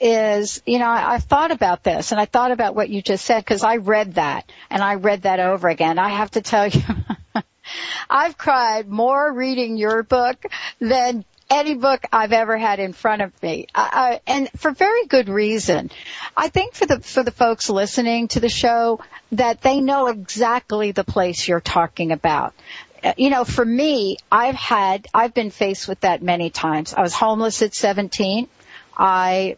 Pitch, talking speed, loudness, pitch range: 225 Hz, 190 wpm, -19 LUFS, 200-250 Hz